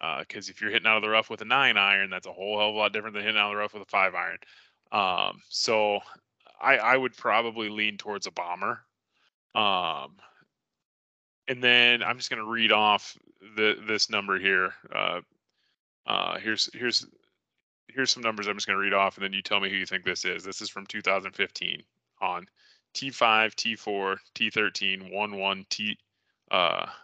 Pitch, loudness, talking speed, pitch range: 105 Hz, -26 LUFS, 190 wpm, 100-110 Hz